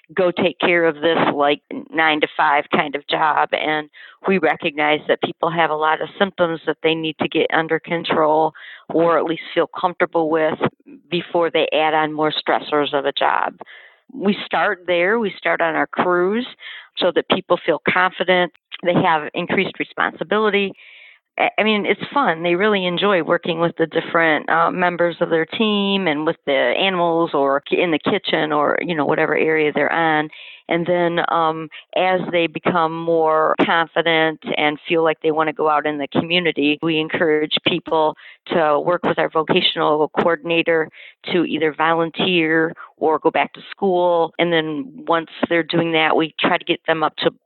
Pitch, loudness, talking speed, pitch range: 165 Hz, -18 LUFS, 180 wpm, 155-175 Hz